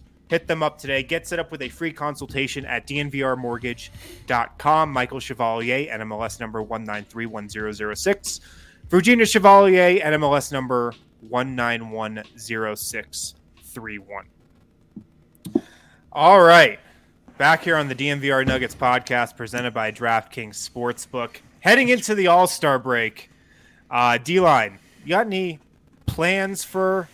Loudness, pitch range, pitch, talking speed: -20 LUFS, 115-155 Hz, 125 Hz, 110 wpm